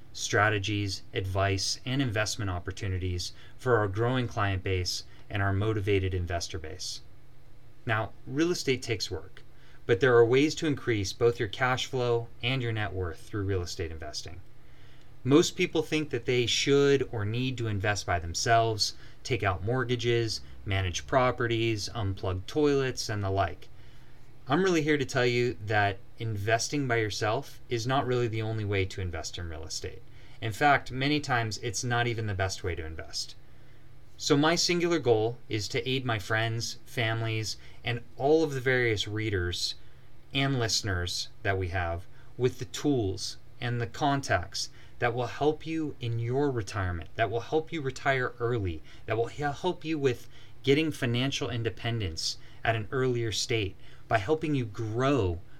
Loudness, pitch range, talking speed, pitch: -29 LUFS, 100-130 Hz, 160 wpm, 115 Hz